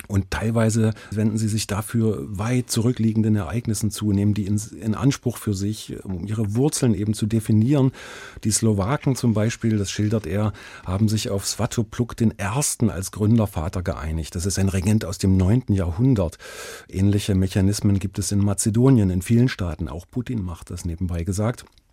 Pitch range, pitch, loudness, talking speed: 100-115 Hz, 105 Hz, -22 LUFS, 165 wpm